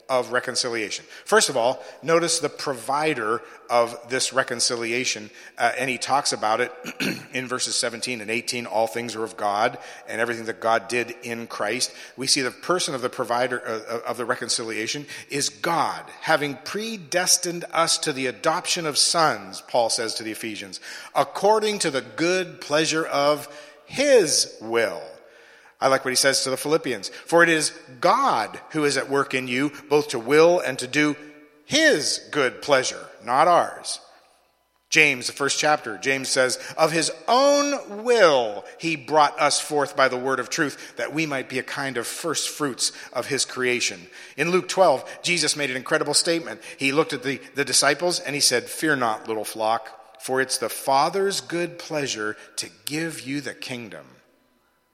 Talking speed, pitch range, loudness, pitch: 175 wpm, 125-160 Hz, -23 LUFS, 140 Hz